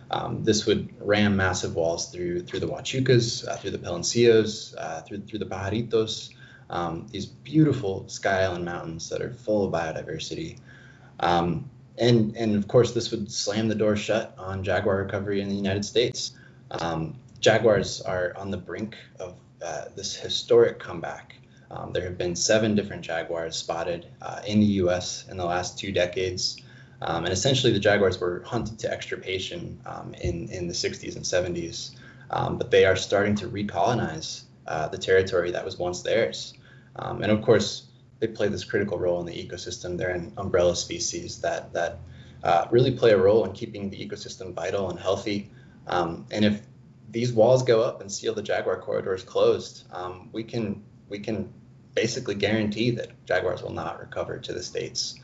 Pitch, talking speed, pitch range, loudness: 105 Hz, 180 wpm, 95-120 Hz, -26 LUFS